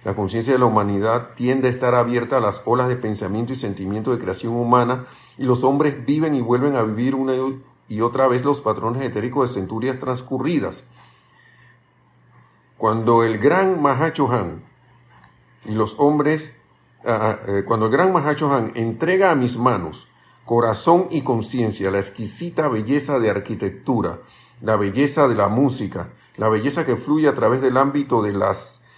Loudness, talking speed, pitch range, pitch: -20 LUFS, 155 wpm, 110-135 Hz, 125 Hz